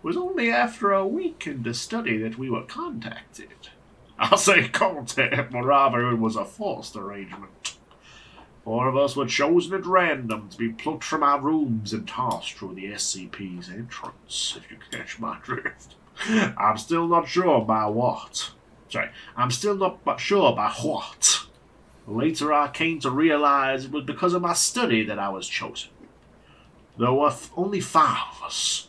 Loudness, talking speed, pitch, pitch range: -24 LUFS, 165 wpm, 135 Hz, 115-165 Hz